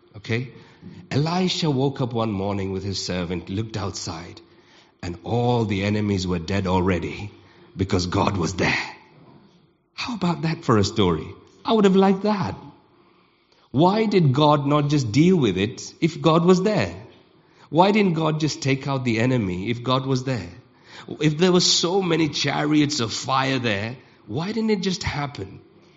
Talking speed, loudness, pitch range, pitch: 165 wpm, -22 LUFS, 100-165 Hz, 130 Hz